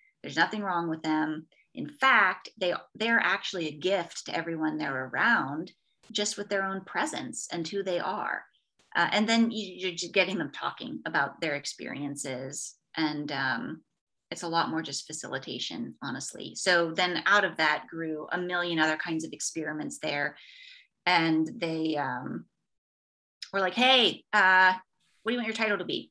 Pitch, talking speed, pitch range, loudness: 175 Hz, 170 wpm, 155-195 Hz, -28 LUFS